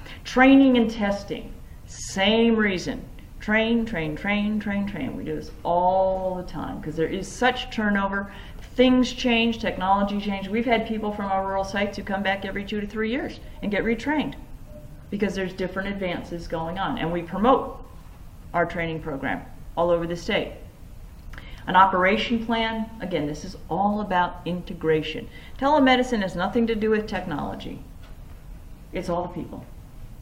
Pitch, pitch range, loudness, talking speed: 195 Hz, 175-225 Hz, -24 LUFS, 155 wpm